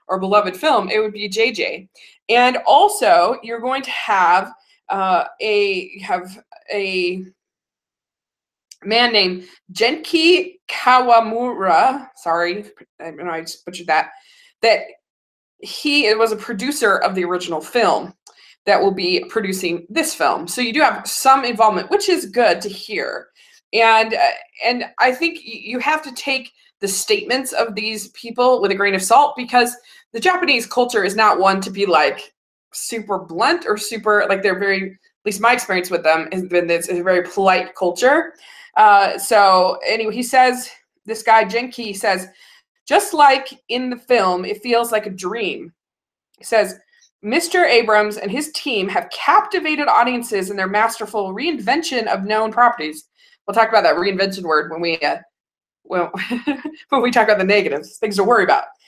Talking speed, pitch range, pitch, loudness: 160 wpm, 195-280 Hz, 225 Hz, -17 LUFS